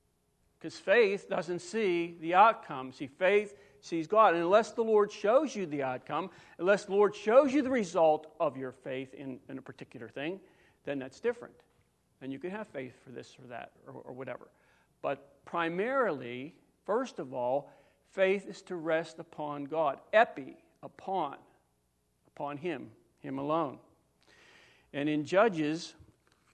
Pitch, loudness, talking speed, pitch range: 165 Hz, -31 LUFS, 155 wpm, 135-200 Hz